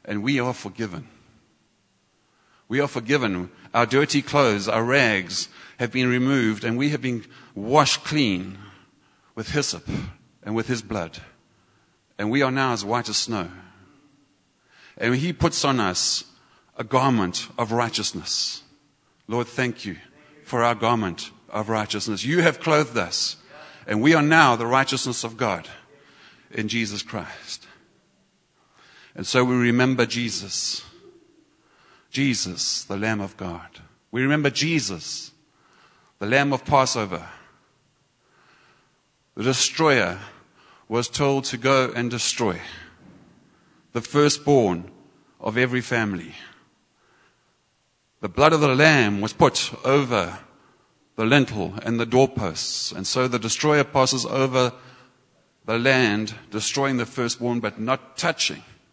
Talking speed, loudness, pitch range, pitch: 125 wpm, -22 LUFS, 110-135 Hz, 120 Hz